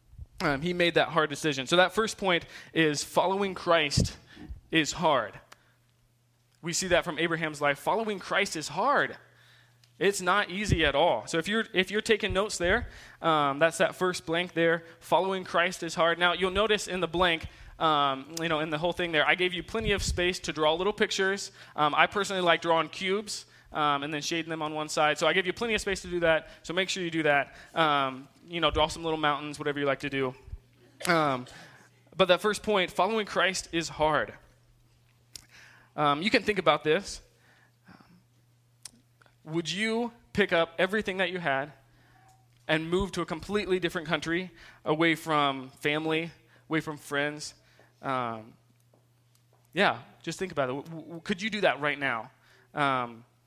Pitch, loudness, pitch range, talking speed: 160 Hz, -28 LUFS, 140-180 Hz, 185 wpm